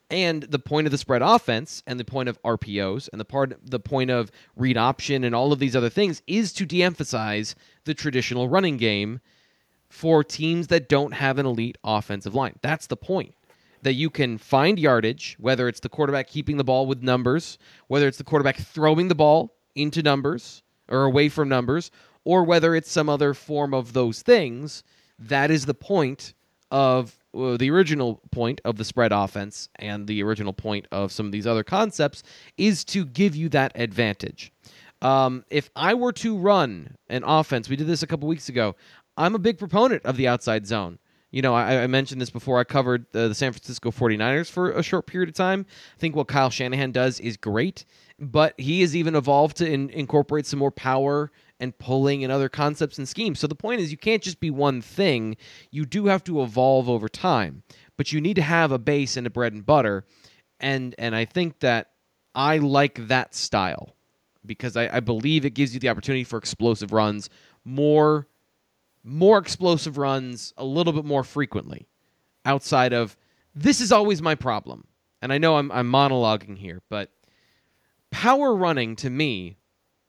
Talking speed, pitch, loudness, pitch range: 195 wpm, 135 Hz, -23 LUFS, 120-155 Hz